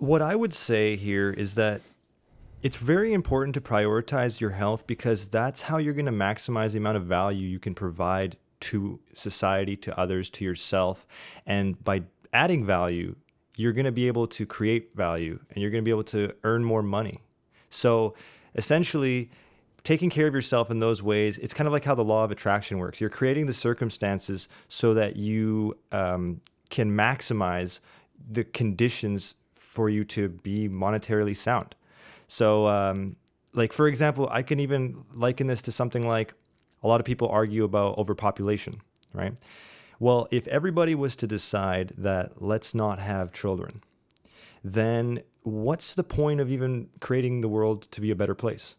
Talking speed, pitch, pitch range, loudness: 170 wpm, 110 Hz, 100-125 Hz, -27 LUFS